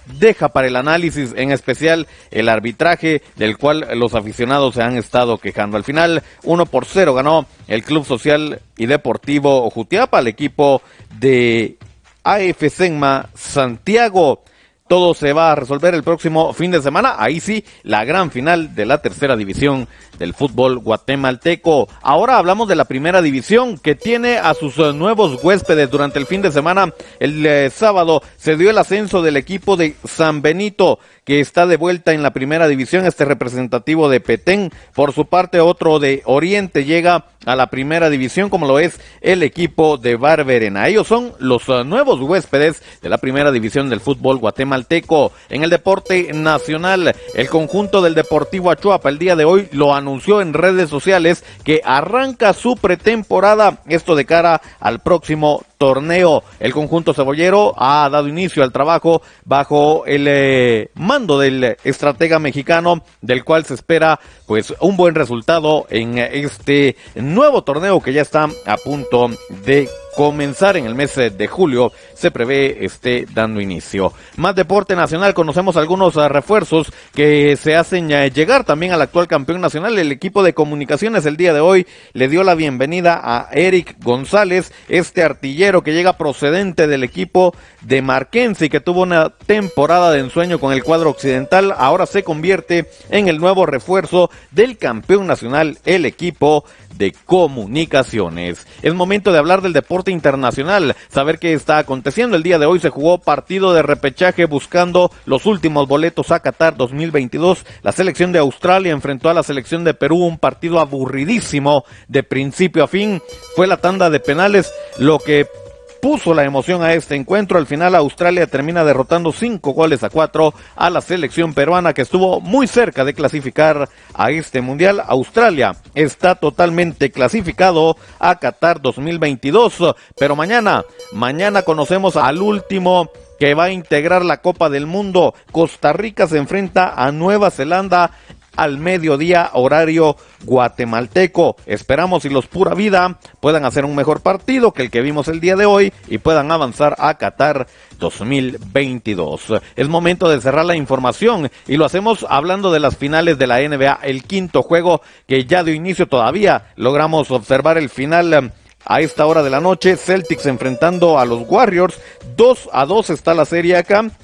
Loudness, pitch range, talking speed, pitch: -14 LUFS, 140-180 Hz, 165 wpm, 155 Hz